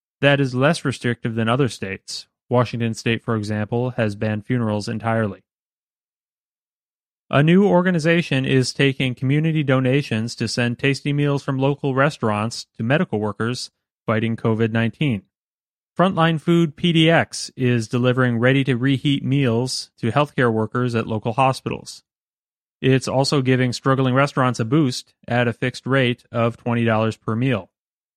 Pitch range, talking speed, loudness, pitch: 115-140 Hz, 140 wpm, -20 LUFS, 125 Hz